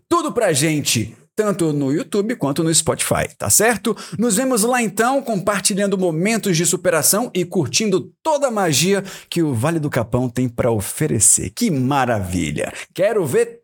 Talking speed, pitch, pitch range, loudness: 160 wpm, 190 Hz, 155-225 Hz, -18 LUFS